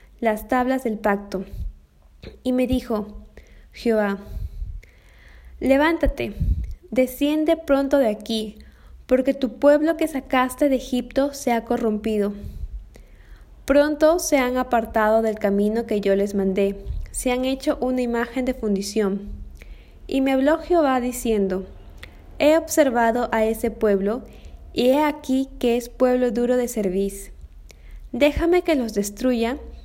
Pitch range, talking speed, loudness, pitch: 200-265 Hz, 125 wpm, -22 LUFS, 235 Hz